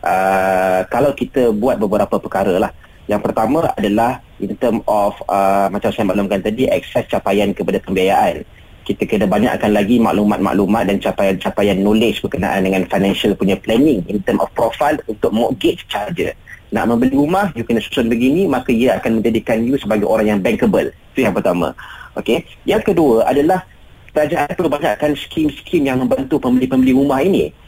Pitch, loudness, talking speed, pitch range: 110 Hz, -16 LUFS, 160 wpm, 100-135 Hz